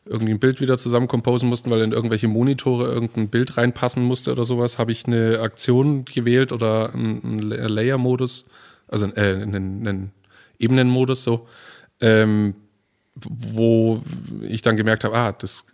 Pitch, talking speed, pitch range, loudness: 115 Hz, 150 wpm, 110-125 Hz, -20 LUFS